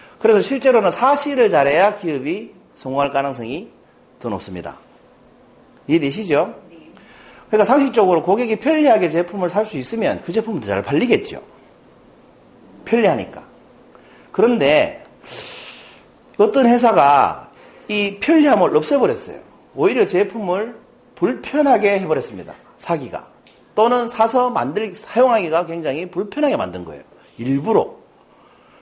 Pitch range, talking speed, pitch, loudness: 180-265 Hz, 285 characters per minute, 220 Hz, -17 LUFS